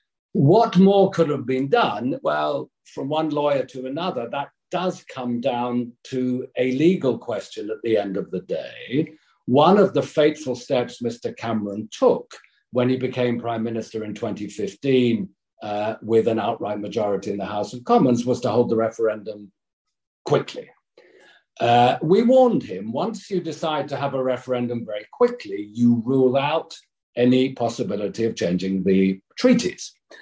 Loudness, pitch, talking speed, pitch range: -22 LUFS, 125 Hz, 155 wpm, 110-150 Hz